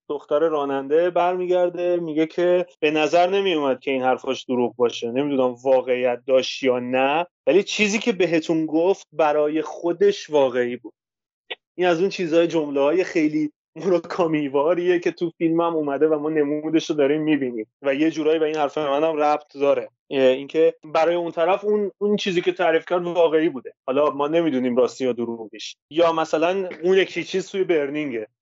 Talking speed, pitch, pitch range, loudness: 170 wpm, 160 Hz, 140-175 Hz, -21 LUFS